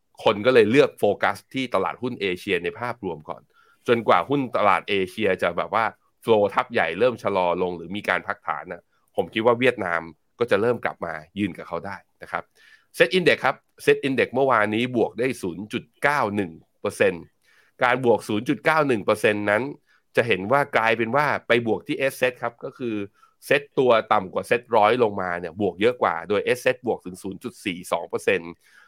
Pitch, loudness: 120 Hz, -23 LUFS